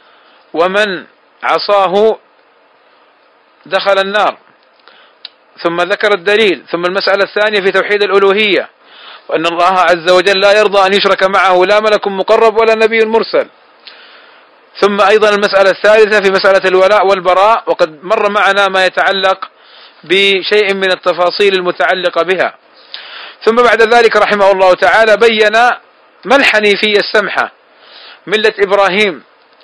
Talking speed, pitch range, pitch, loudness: 115 wpm, 185-210 Hz, 195 Hz, -10 LUFS